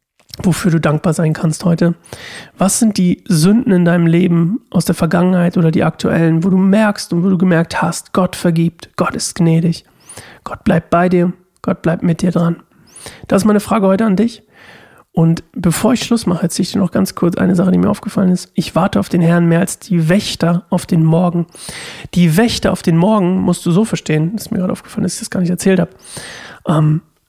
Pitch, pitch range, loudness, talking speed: 180 Hz, 170-195 Hz, -14 LUFS, 220 wpm